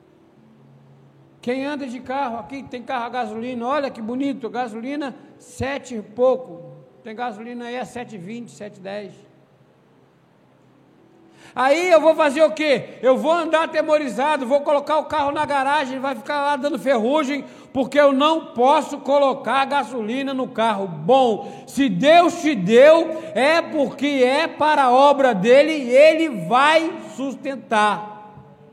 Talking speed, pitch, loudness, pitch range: 140 wpm, 270 Hz, -19 LUFS, 240-290 Hz